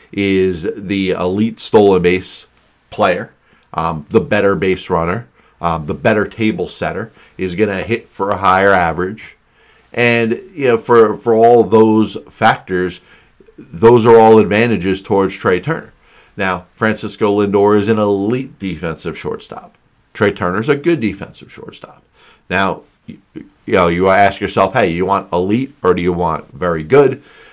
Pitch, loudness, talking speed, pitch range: 100 Hz, -14 LUFS, 155 wpm, 90-110 Hz